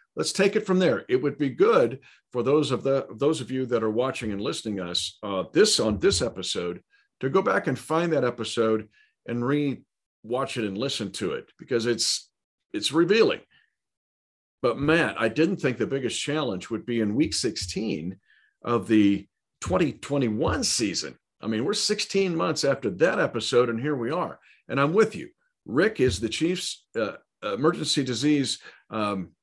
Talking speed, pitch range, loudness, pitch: 180 wpm, 110-160 Hz, -25 LUFS, 125 Hz